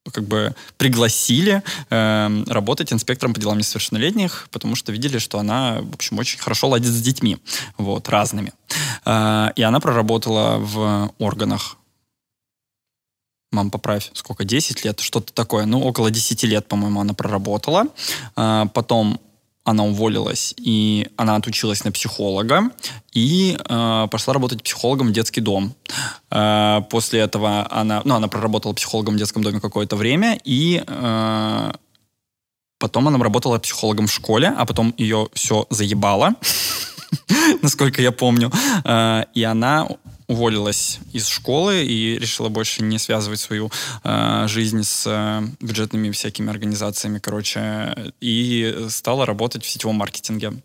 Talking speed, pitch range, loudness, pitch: 135 wpm, 105-120 Hz, -19 LUFS, 110 Hz